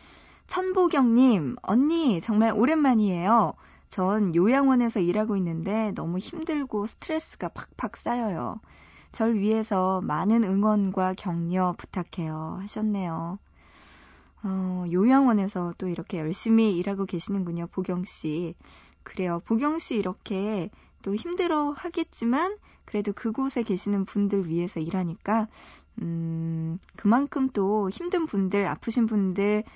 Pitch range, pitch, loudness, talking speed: 180-235 Hz, 200 Hz, -26 LUFS, 270 characters per minute